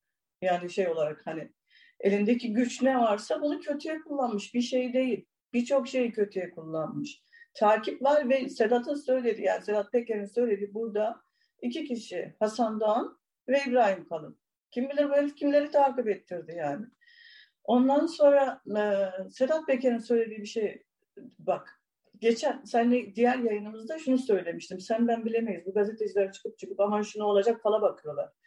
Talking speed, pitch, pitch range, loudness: 145 wpm, 235 Hz, 205-270 Hz, -28 LUFS